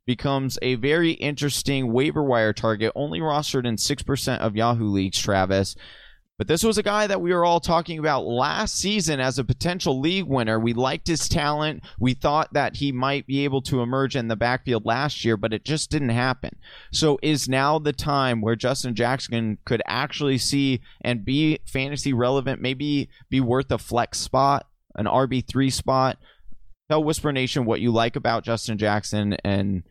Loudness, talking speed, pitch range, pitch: -23 LUFS, 180 wpm, 115-145 Hz, 130 Hz